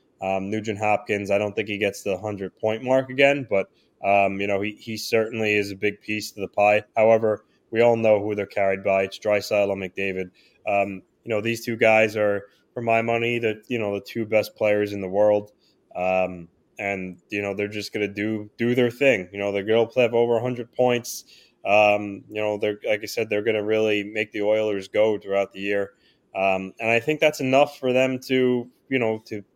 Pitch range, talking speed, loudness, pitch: 100-115 Hz, 225 wpm, -23 LUFS, 105 Hz